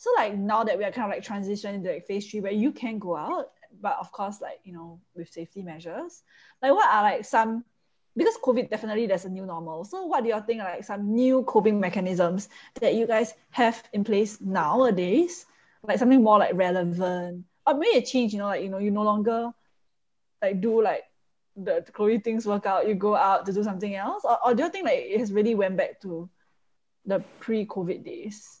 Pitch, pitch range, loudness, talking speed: 210 Hz, 195-235 Hz, -25 LUFS, 220 wpm